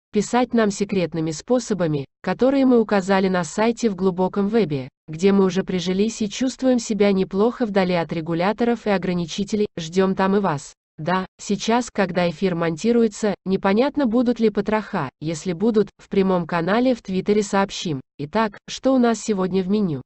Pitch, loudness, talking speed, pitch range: 200 Hz, -21 LUFS, 160 wpm, 180-225 Hz